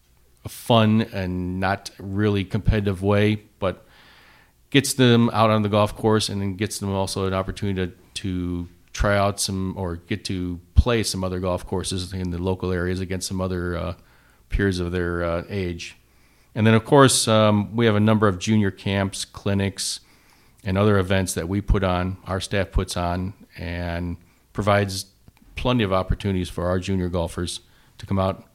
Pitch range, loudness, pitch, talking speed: 90-105 Hz, -23 LUFS, 95 Hz, 175 wpm